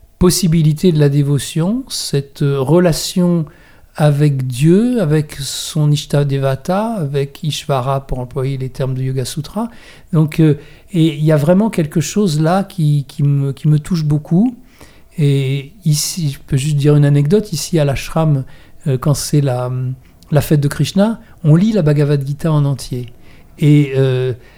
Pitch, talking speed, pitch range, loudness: 150 Hz, 155 wpm, 140-165 Hz, -15 LUFS